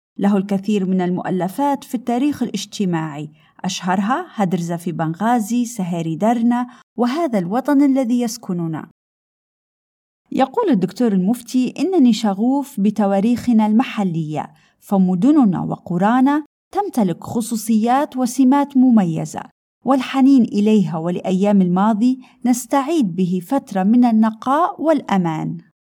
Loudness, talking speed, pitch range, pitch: -18 LUFS, 95 wpm, 190-255 Hz, 225 Hz